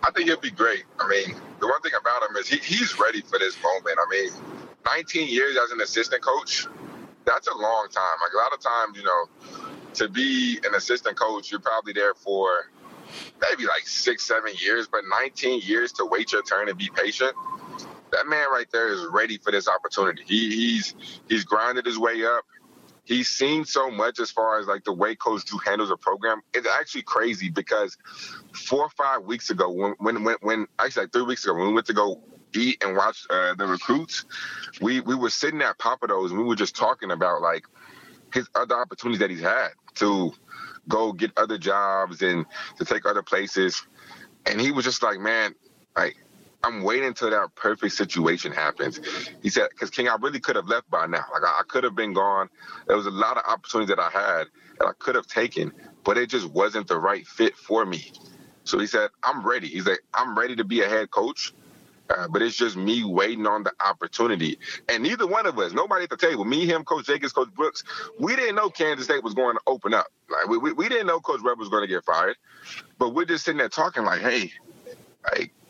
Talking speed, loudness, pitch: 220 wpm, -24 LUFS, 270 Hz